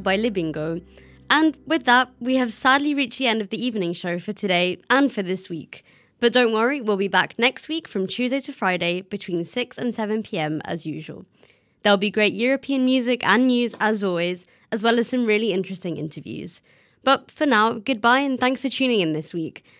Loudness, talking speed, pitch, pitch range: -22 LUFS, 205 wpm, 220 Hz, 185-255 Hz